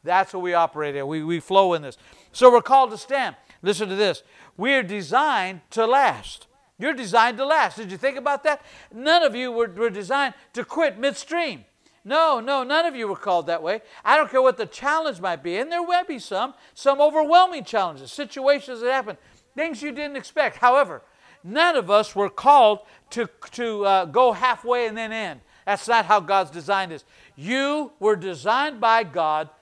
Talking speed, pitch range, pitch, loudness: 200 wpm, 195-280 Hz, 235 Hz, -21 LUFS